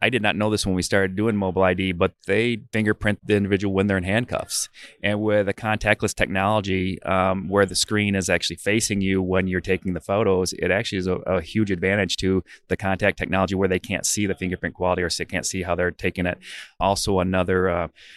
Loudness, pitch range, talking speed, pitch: -22 LUFS, 90-105 Hz, 225 wpm, 95 Hz